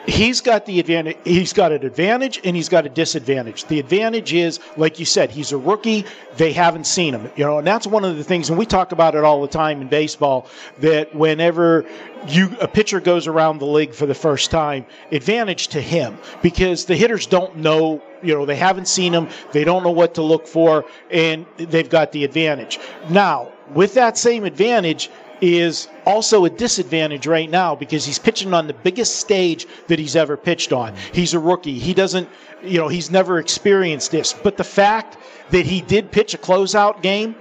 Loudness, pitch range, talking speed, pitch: -17 LUFS, 155-190 Hz, 205 wpm, 170 Hz